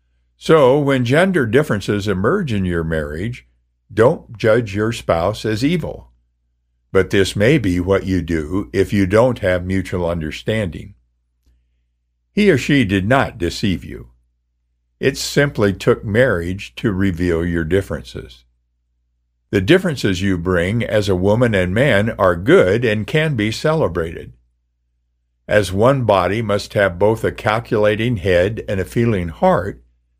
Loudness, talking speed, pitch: -17 LUFS, 140 wpm, 95 Hz